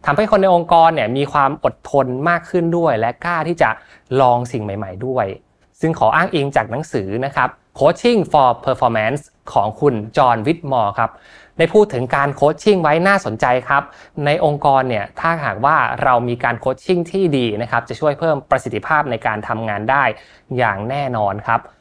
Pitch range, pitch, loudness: 120-160 Hz, 140 Hz, -17 LUFS